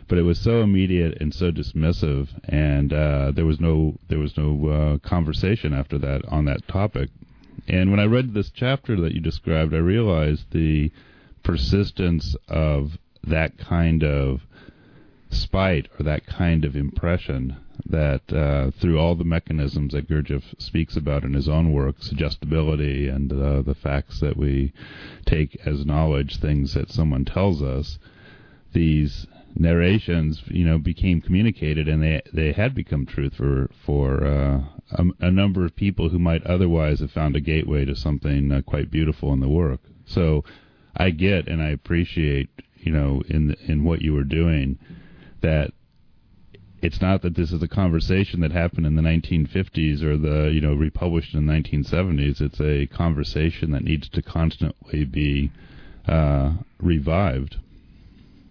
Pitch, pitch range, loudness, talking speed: 80 Hz, 75-85 Hz, -22 LUFS, 160 wpm